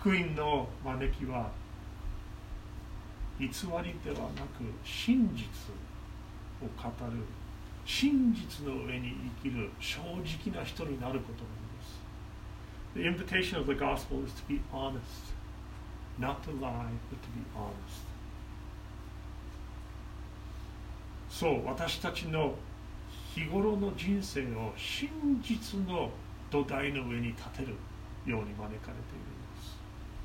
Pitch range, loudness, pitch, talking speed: 105-145 Hz, -36 LUFS, 120 Hz, 260 characters per minute